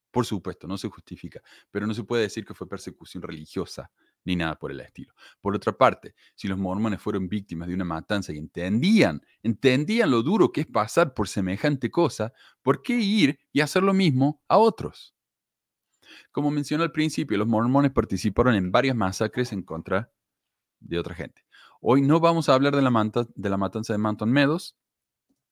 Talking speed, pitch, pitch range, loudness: 185 wpm, 110 Hz, 95-140 Hz, -24 LUFS